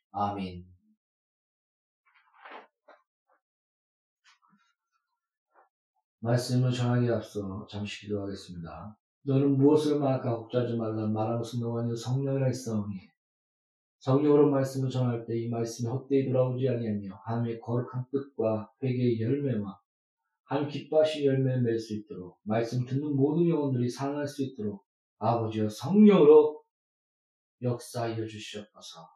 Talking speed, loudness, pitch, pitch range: 270 characters per minute, -28 LUFS, 120 Hz, 110-140 Hz